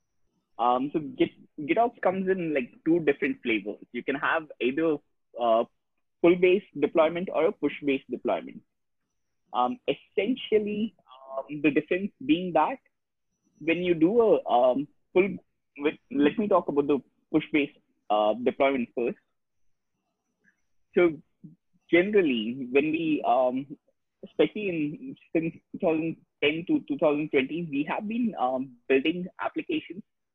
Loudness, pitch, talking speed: -27 LUFS, 170 Hz, 120 wpm